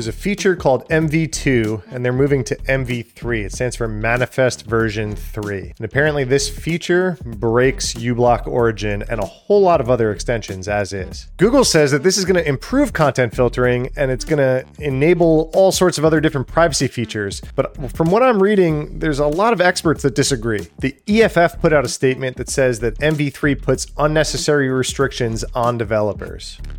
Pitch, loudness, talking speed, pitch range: 130 Hz, -17 LUFS, 180 wpm, 115-160 Hz